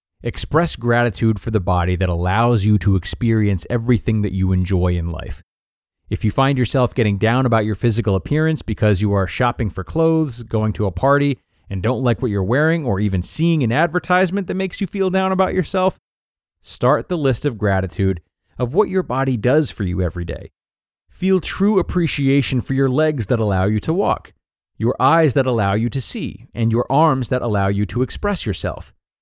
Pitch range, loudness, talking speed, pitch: 100-145 Hz, -19 LUFS, 195 wpm, 120 Hz